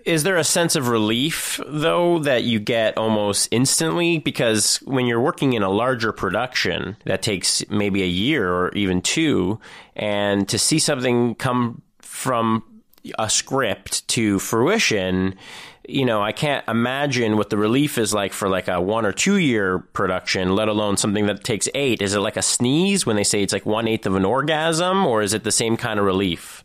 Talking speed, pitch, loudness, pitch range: 190 wpm, 110 Hz, -20 LUFS, 100-130 Hz